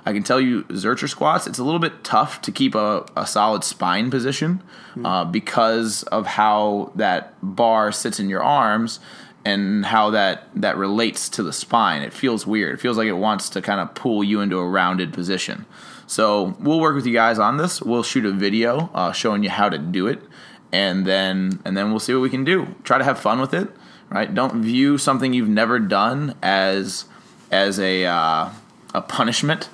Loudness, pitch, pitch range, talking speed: -20 LUFS, 110 Hz, 100-130 Hz, 205 wpm